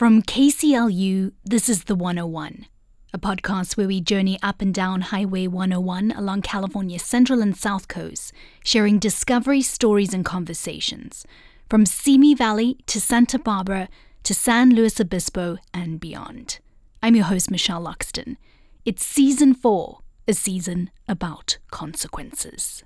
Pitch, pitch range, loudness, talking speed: 200 Hz, 185-230 Hz, -20 LUFS, 135 wpm